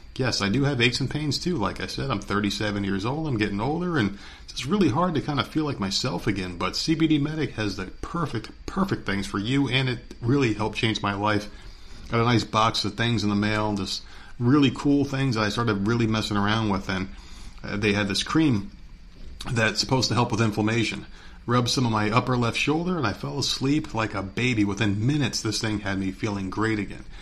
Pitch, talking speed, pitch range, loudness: 110 Hz, 225 wpm, 100-130 Hz, -25 LUFS